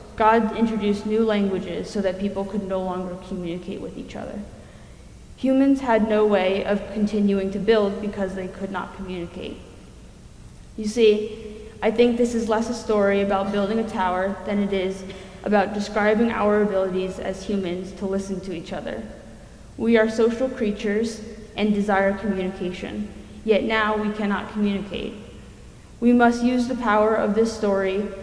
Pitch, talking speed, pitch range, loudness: 205 Hz, 155 wpm, 190-220 Hz, -23 LUFS